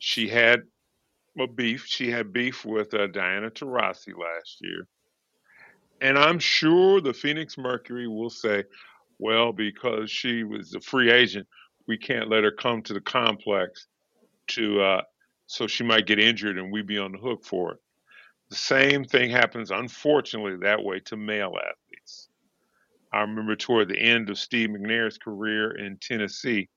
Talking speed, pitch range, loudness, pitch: 160 wpm, 105-125 Hz, -24 LUFS, 115 Hz